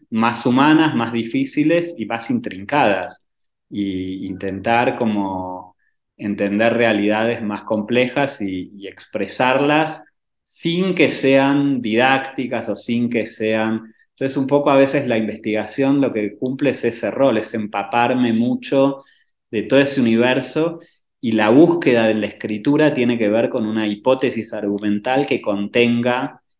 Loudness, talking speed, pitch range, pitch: -18 LUFS, 135 wpm, 110-135 Hz, 120 Hz